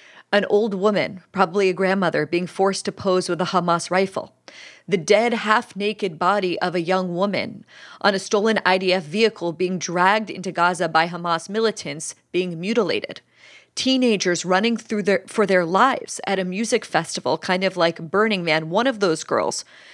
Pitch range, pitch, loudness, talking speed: 175-210 Hz, 190 Hz, -21 LUFS, 170 wpm